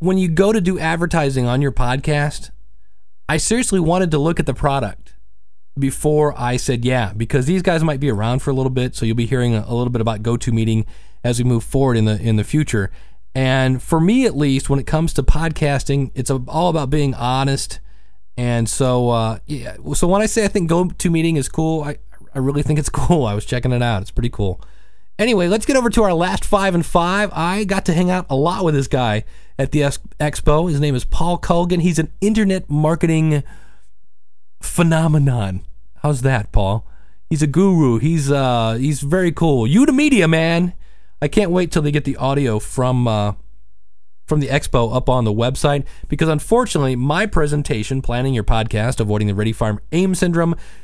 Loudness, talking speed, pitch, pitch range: -18 LUFS, 200 wpm, 140 Hz, 120-165 Hz